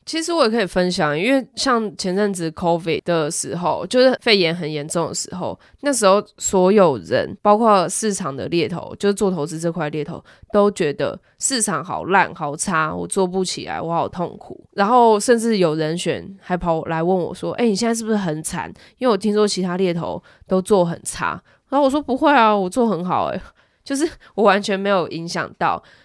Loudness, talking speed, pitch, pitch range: -19 LUFS, 300 characters per minute, 195 Hz, 170-225 Hz